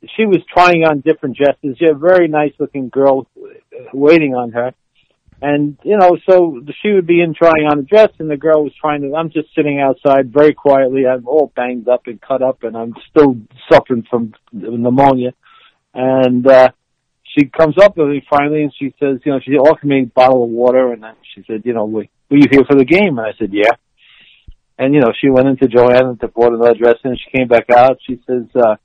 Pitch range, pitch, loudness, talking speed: 125-150 Hz, 135 Hz, -12 LUFS, 225 wpm